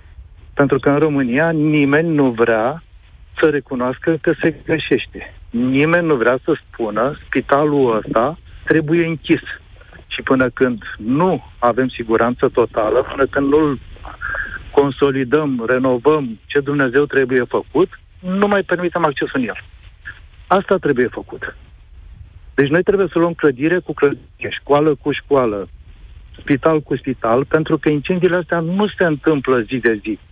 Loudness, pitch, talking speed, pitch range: -17 LUFS, 140 Hz, 140 wpm, 120-160 Hz